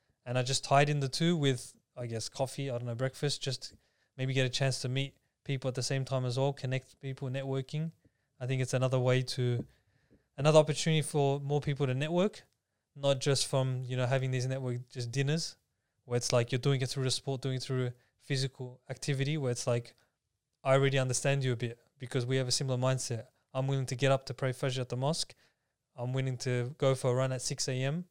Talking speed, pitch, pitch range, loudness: 230 wpm, 130 Hz, 125-140 Hz, -32 LUFS